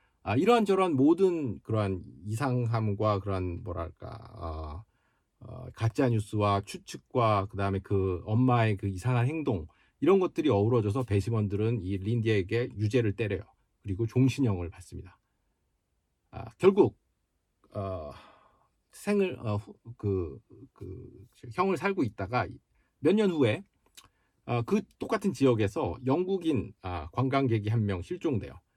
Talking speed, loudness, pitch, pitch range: 260 characters per minute, -29 LUFS, 110 Hz, 95-125 Hz